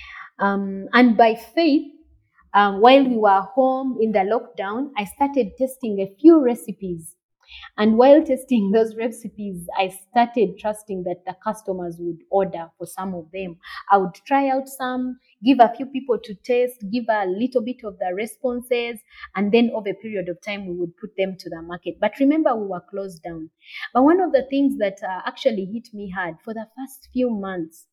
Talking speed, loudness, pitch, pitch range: 190 wpm, -21 LUFS, 215 Hz, 190-250 Hz